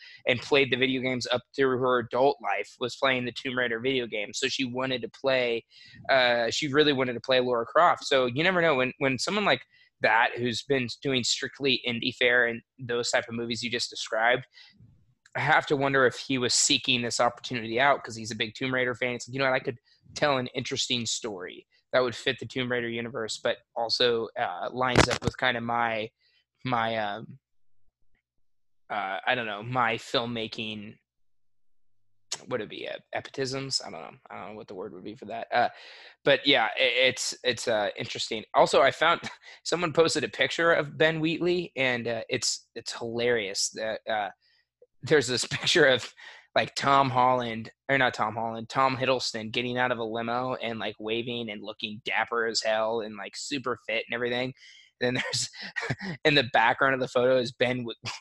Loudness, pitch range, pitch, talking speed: -26 LUFS, 115-135 Hz, 125 Hz, 200 wpm